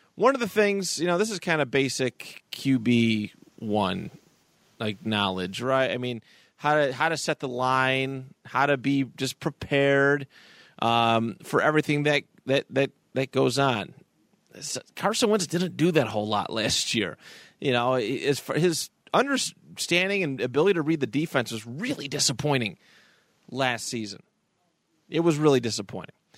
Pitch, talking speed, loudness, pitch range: 135 Hz, 150 wpm, -25 LUFS, 120-160 Hz